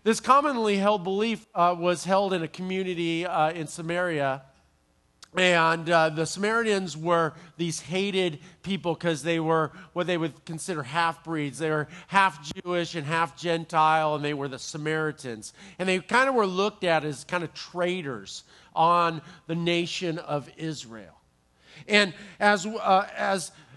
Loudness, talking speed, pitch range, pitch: -26 LUFS, 155 wpm, 155-185 Hz, 170 Hz